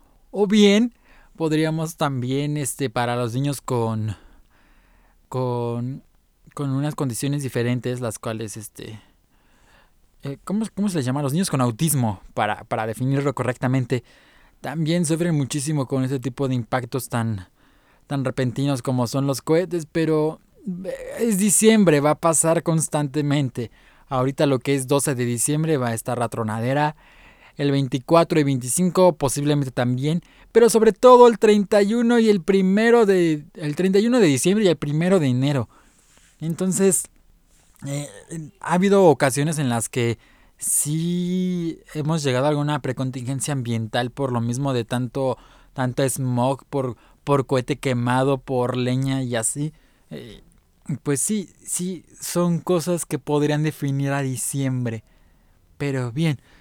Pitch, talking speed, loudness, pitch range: 140 Hz, 140 wpm, -21 LUFS, 125-165 Hz